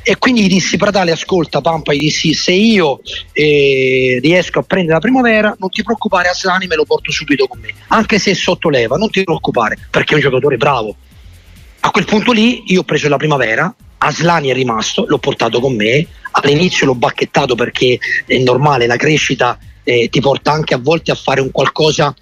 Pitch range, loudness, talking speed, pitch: 135-190 Hz, -12 LUFS, 200 wpm, 155 Hz